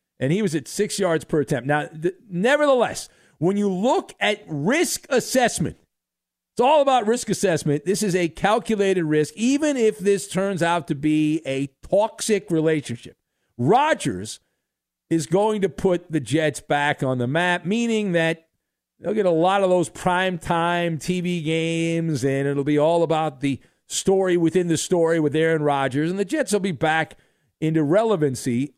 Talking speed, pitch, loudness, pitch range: 165 wpm, 170 Hz, -21 LUFS, 155-195 Hz